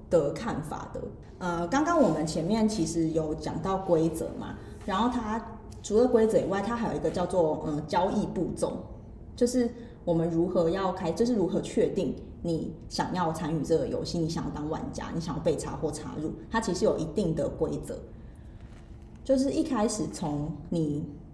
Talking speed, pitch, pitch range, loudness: 260 characters per minute, 175 Hz, 160-225 Hz, -29 LUFS